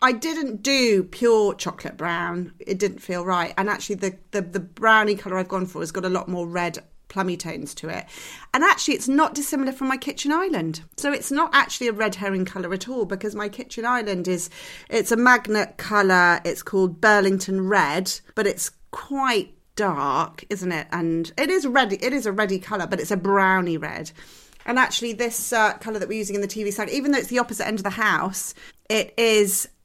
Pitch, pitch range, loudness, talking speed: 205 Hz, 185-240 Hz, -22 LUFS, 210 wpm